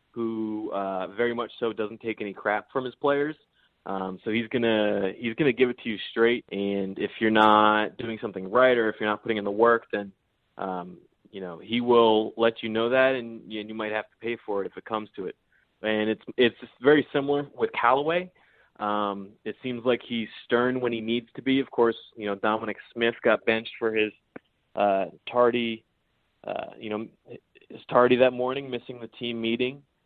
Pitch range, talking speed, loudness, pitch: 105-120 Hz, 210 wpm, -26 LUFS, 115 Hz